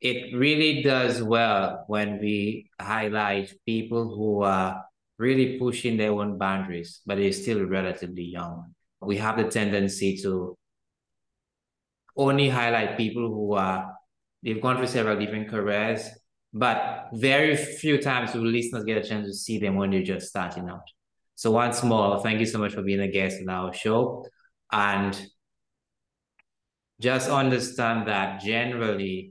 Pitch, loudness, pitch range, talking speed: 105 Hz, -25 LUFS, 100-120 Hz, 145 wpm